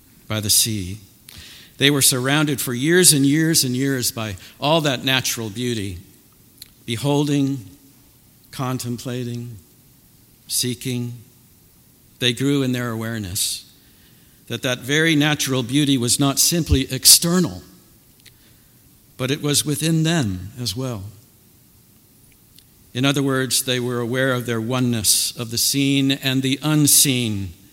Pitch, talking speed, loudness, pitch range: 125 Hz, 120 wpm, -18 LUFS, 115-140 Hz